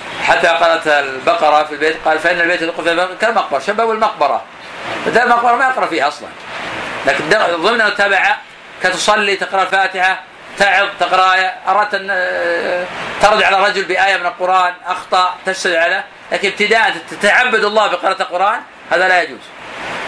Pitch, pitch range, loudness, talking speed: 185 Hz, 175-200 Hz, -14 LUFS, 145 wpm